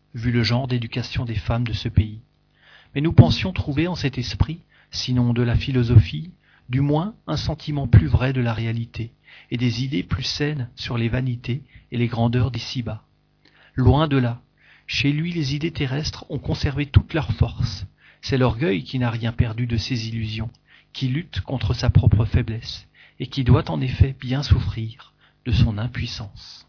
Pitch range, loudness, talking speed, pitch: 115-135 Hz, -22 LUFS, 180 wpm, 120 Hz